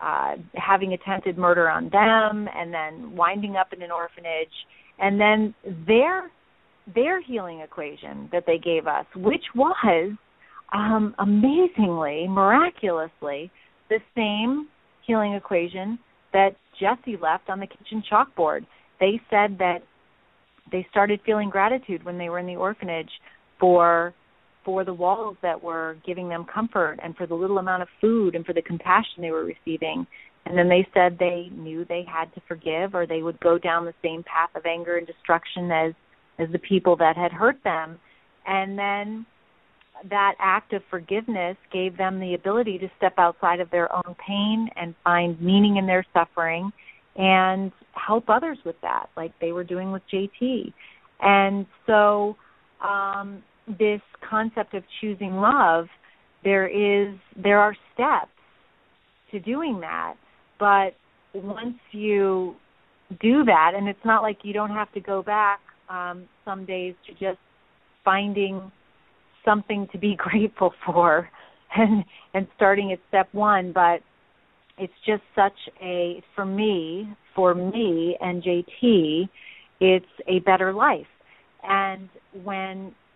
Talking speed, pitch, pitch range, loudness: 150 wpm, 190 Hz, 175-205 Hz, -23 LUFS